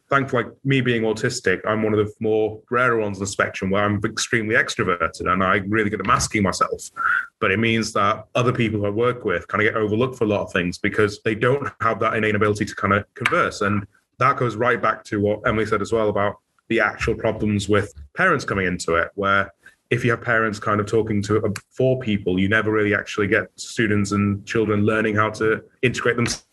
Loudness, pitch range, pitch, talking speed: -21 LUFS, 105-115 Hz, 110 Hz, 225 wpm